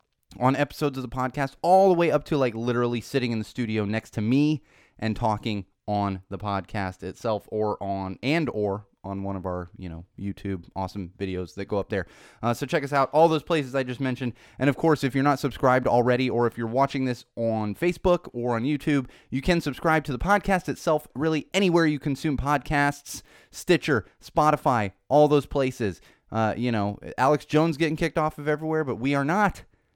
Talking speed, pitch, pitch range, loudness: 205 wpm, 125 Hz, 105-150 Hz, -25 LUFS